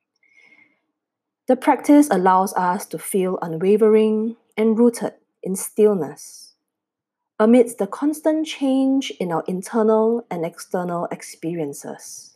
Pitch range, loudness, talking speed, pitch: 185-240 Hz, -20 LUFS, 100 wpm, 215 Hz